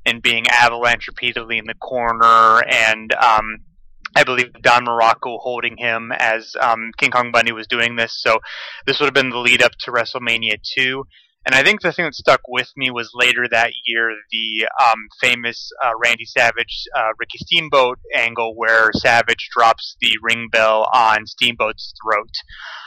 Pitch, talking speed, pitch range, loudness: 115 Hz, 175 wpm, 115-120 Hz, -16 LUFS